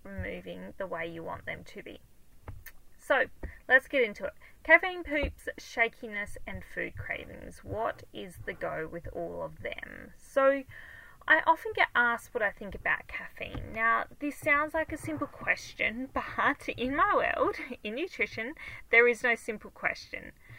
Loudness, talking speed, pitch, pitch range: -30 LUFS, 160 wpm, 265 Hz, 235-310 Hz